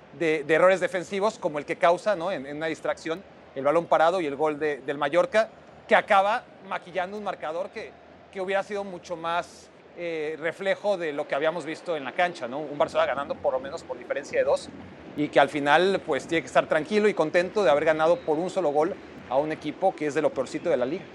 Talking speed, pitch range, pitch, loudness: 235 wpm, 155-185 Hz, 170 Hz, -26 LUFS